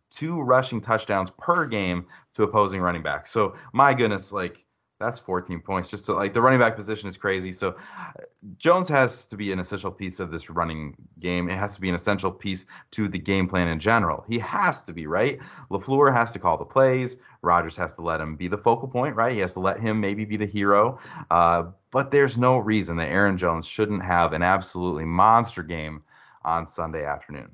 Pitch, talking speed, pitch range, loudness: 95 Hz, 210 wpm, 90-115 Hz, -24 LUFS